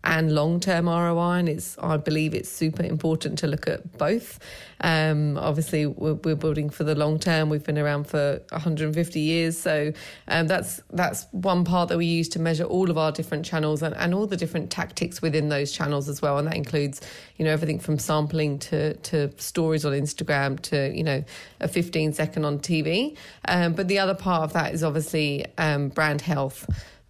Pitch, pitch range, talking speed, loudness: 155 Hz, 150-165 Hz, 190 wpm, -25 LUFS